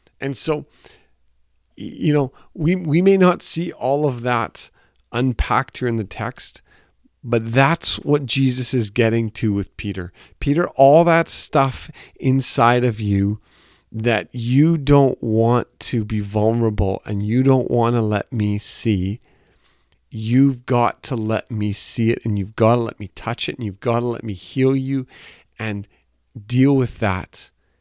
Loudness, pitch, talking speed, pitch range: -19 LUFS, 120 Hz, 160 wpm, 105-135 Hz